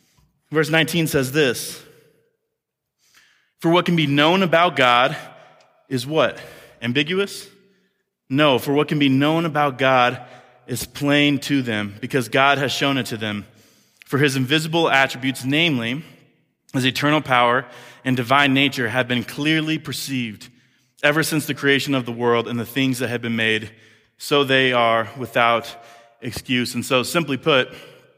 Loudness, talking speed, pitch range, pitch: -19 LUFS, 150 wpm, 120-150 Hz, 135 Hz